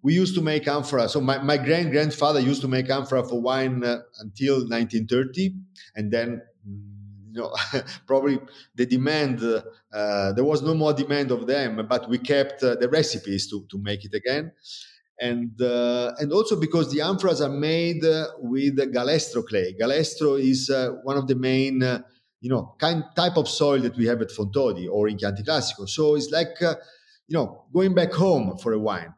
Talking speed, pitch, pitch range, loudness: 190 wpm, 135 Hz, 120-155 Hz, -24 LUFS